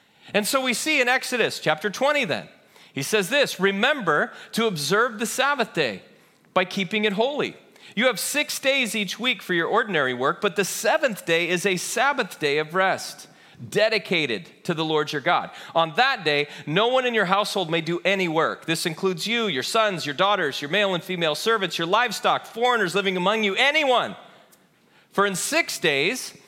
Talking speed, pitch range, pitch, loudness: 190 wpm, 175-235 Hz, 205 Hz, -22 LUFS